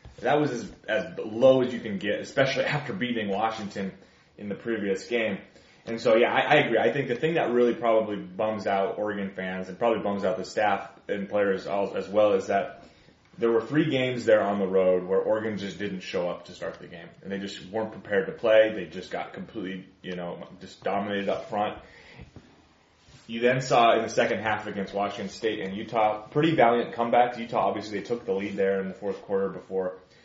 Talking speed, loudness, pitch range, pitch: 220 wpm, -26 LUFS, 95-115 Hz, 105 Hz